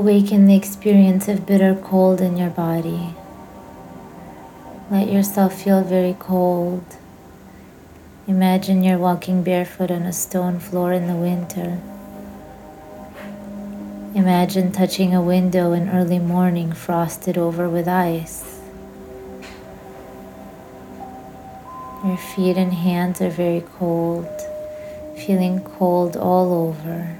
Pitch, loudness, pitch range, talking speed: 180 Hz, -19 LUFS, 170-190 Hz, 105 wpm